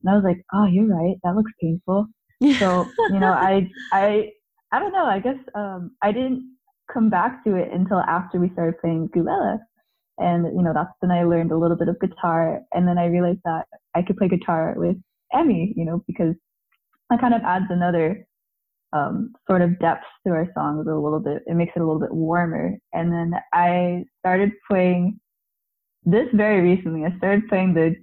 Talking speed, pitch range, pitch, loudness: 200 wpm, 170-210 Hz, 185 Hz, -21 LUFS